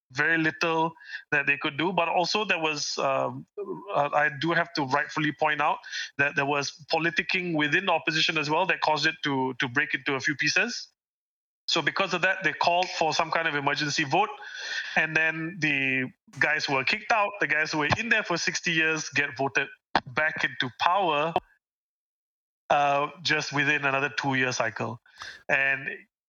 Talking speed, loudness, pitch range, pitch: 180 wpm, -25 LUFS, 145-170 Hz, 155 Hz